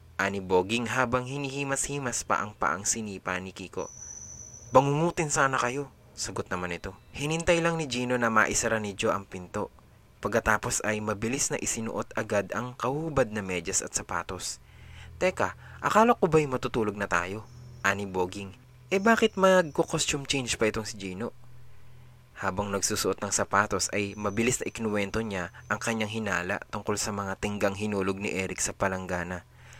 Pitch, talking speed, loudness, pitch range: 110 Hz, 155 wpm, -28 LUFS, 100-125 Hz